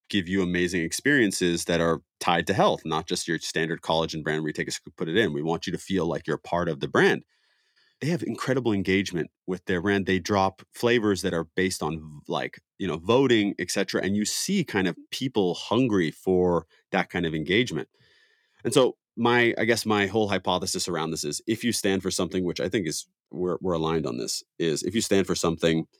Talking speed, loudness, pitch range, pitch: 225 wpm, -26 LUFS, 85-100 Hz, 95 Hz